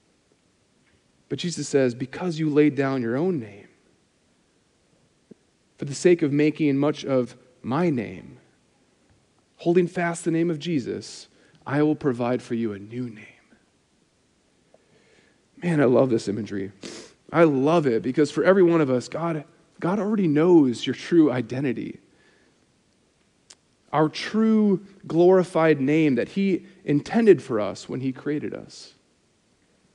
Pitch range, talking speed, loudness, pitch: 130-170 Hz, 135 wpm, -23 LUFS, 150 Hz